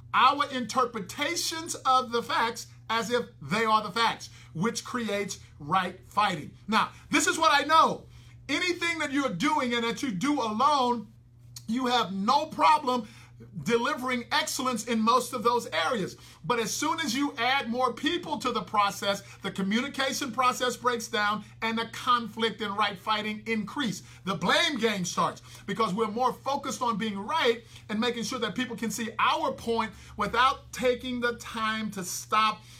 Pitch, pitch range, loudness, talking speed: 235 Hz, 210-260 Hz, -27 LUFS, 165 wpm